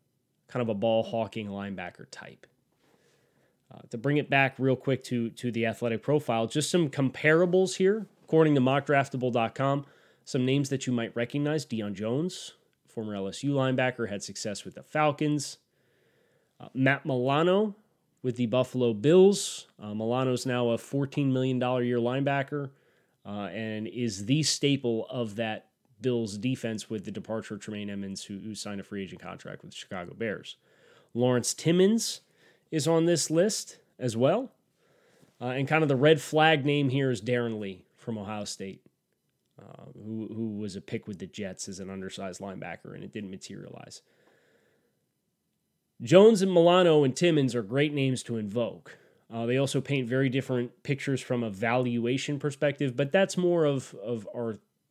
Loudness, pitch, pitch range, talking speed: -28 LUFS, 130 Hz, 115-145 Hz, 165 wpm